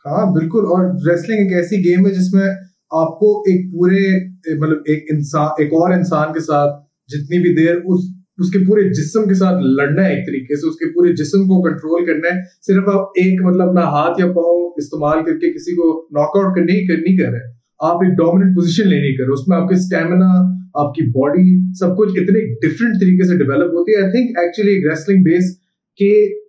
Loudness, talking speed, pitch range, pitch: -14 LUFS, 180 wpm, 160-190 Hz, 180 Hz